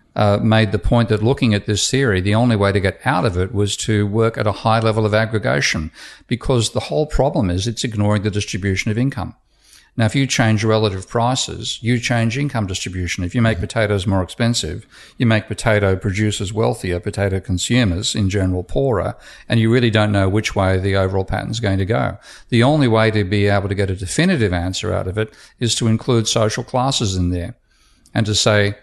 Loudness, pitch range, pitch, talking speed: -18 LUFS, 100-115 Hz, 110 Hz, 210 wpm